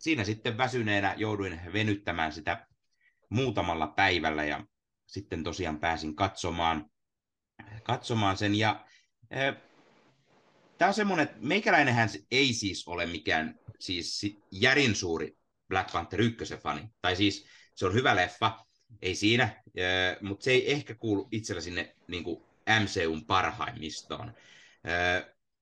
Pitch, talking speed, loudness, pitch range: 100 Hz, 120 wpm, -29 LUFS, 85-110 Hz